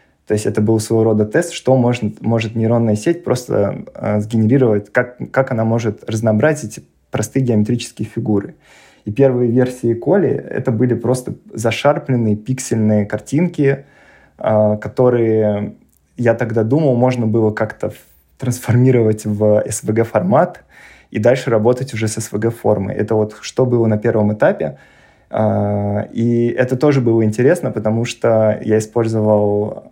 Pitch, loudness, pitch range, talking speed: 115 Hz, -16 LUFS, 105-125 Hz, 135 wpm